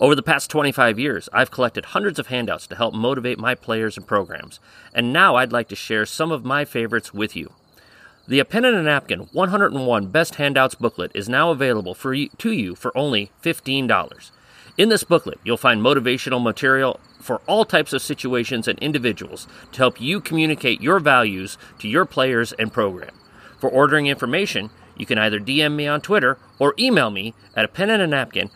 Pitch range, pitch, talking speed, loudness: 115-155 Hz, 130 Hz, 195 wpm, -19 LUFS